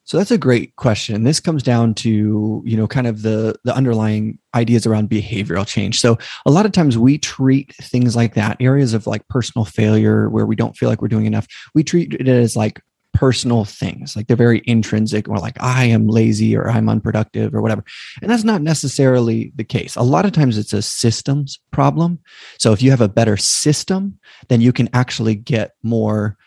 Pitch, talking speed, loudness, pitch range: 115 Hz, 205 wpm, -16 LUFS, 110-130 Hz